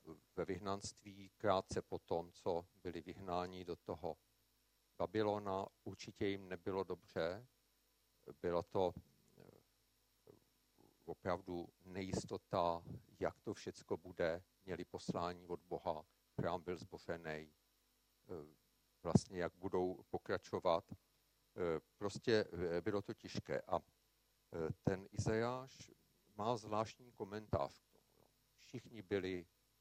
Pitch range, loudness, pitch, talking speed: 90-105 Hz, -44 LUFS, 95 Hz, 95 wpm